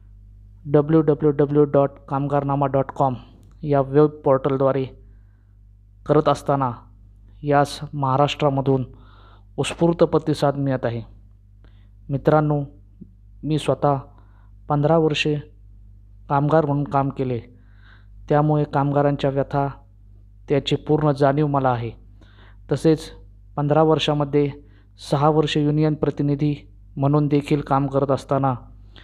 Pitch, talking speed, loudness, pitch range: 140 Hz, 95 wpm, -21 LUFS, 100-145 Hz